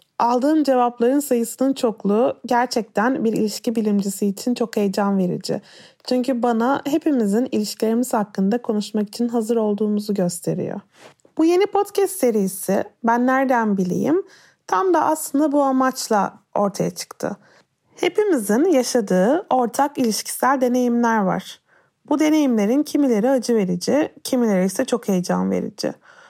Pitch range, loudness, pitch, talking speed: 210-270 Hz, -20 LUFS, 240 Hz, 120 wpm